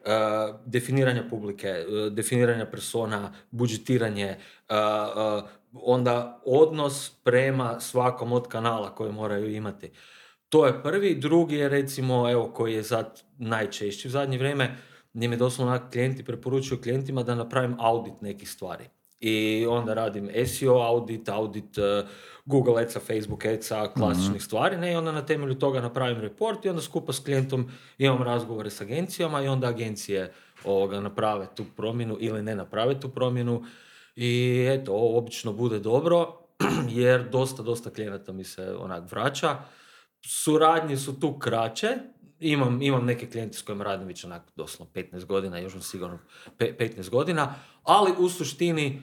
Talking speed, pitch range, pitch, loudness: 145 wpm, 110-130 Hz, 120 Hz, -27 LUFS